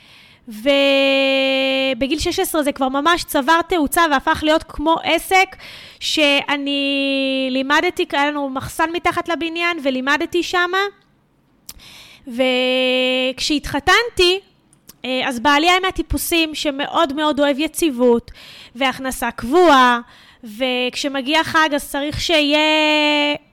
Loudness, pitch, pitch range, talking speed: -17 LUFS, 290 Hz, 270-330 Hz, 90 wpm